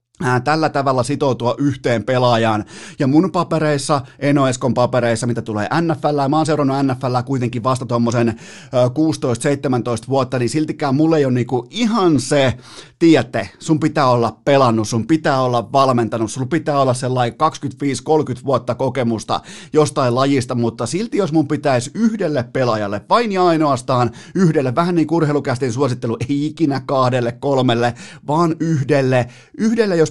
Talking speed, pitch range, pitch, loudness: 145 wpm, 125-155 Hz, 135 Hz, -17 LUFS